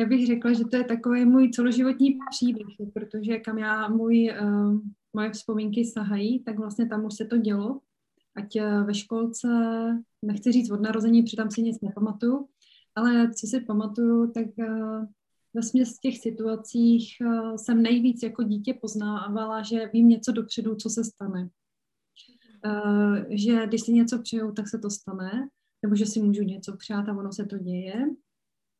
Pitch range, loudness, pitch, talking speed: 210-235 Hz, -26 LUFS, 225 Hz, 170 wpm